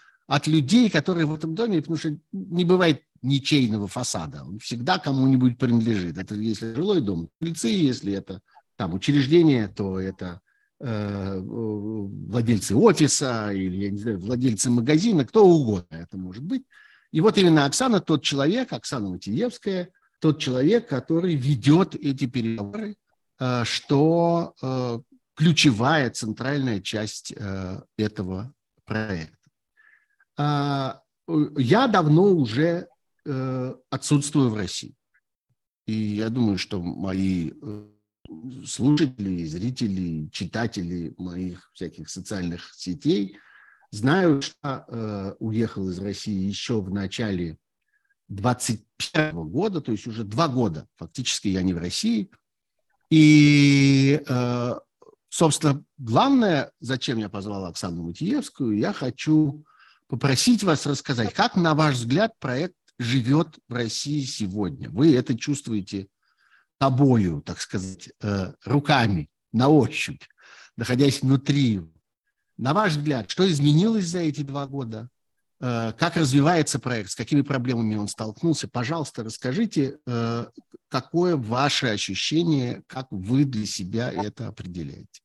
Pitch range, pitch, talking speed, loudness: 105-155 Hz, 130 Hz, 115 wpm, -23 LUFS